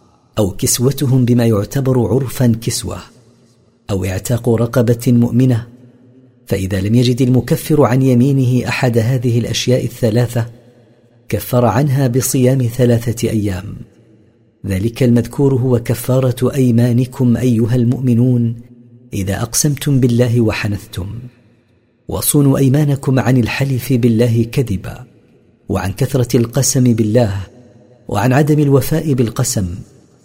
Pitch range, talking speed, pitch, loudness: 115-130 Hz, 100 wpm, 120 Hz, -14 LUFS